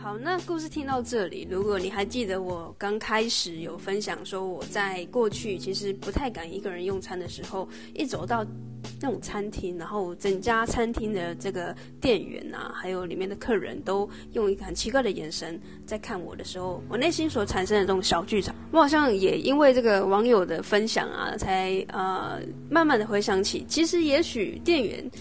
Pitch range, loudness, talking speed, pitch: 185-230 Hz, -27 LUFS, 290 characters per minute, 200 Hz